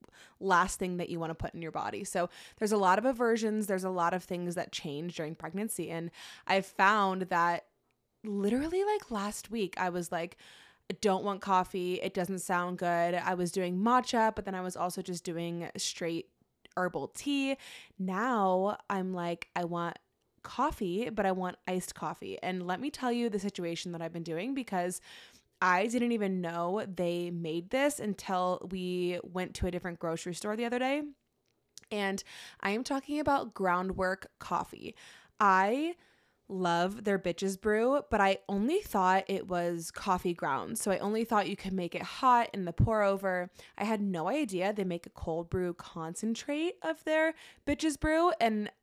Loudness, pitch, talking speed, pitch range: -32 LUFS, 190 Hz, 180 wpm, 180-220 Hz